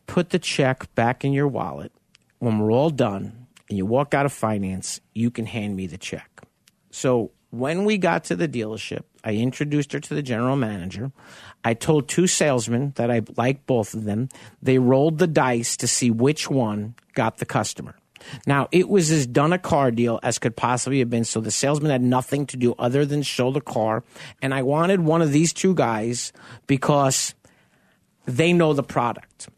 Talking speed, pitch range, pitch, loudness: 195 wpm, 115-150 Hz, 130 Hz, -22 LUFS